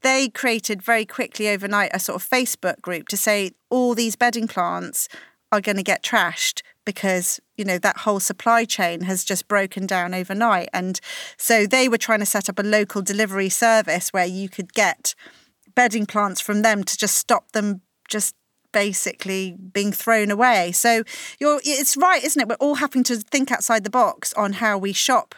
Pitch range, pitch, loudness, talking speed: 195-245 Hz, 215 Hz, -20 LUFS, 190 wpm